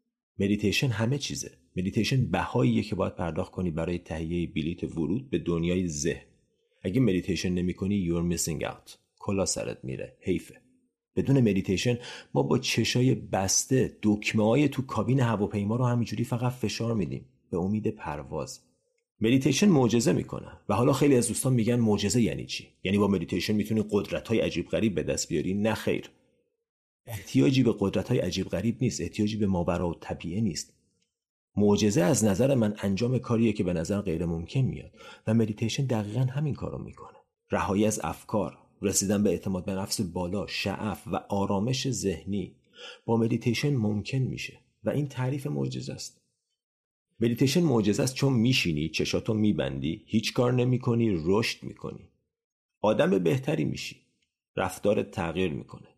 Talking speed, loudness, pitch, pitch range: 150 wpm, -28 LUFS, 105 Hz, 95-125 Hz